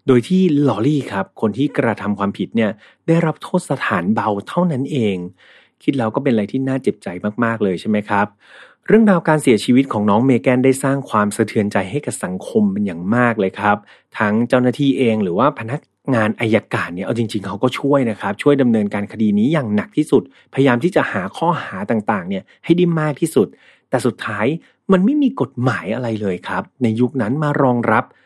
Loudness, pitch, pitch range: -18 LUFS, 125 Hz, 105-145 Hz